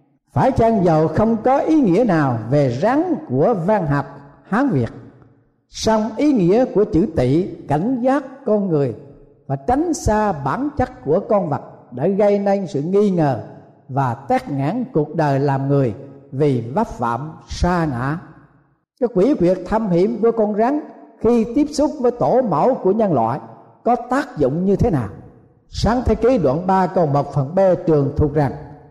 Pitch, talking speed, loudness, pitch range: 165 Hz, 180 wpm, -18 LUFS, 140-225 Hz